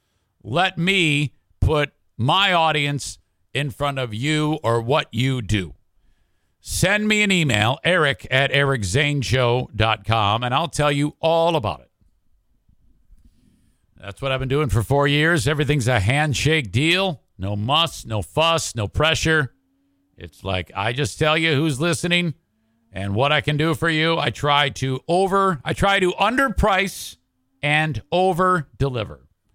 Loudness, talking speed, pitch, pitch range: -20 LUFS, 145 wpm, 135 Hz, 105-155 Hz